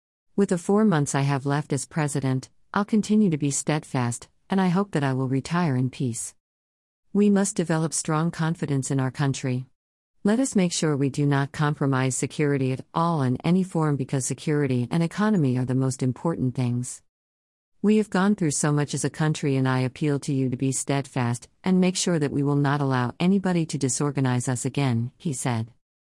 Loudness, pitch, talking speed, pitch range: -24 LUFS, 140 Hz, 200 wpm, 130-165 Hz